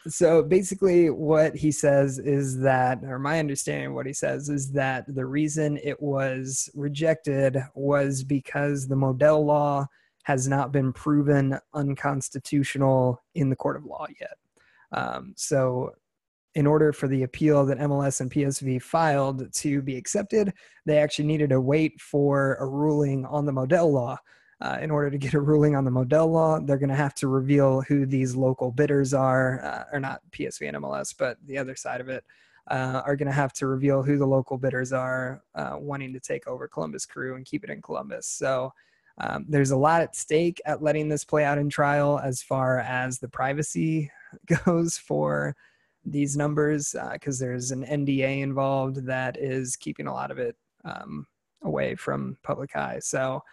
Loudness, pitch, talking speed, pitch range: -25 LUFS, 140 Hz, 185 wpm, 130-150 Hz